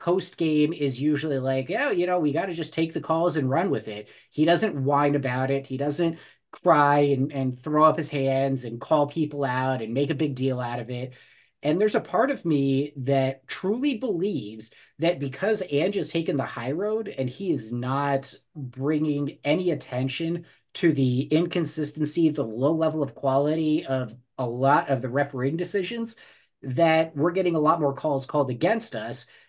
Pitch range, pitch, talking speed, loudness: 135-165 Hz, 145 Hz, 195 wpm, -25 LUFS